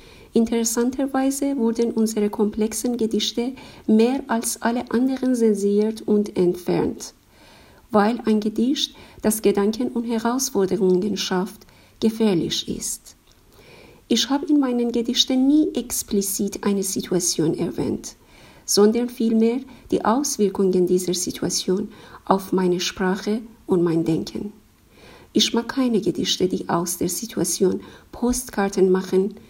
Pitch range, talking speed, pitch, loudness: 195-240 Hz, 110 wpm, 215 Hz, -21 LUFS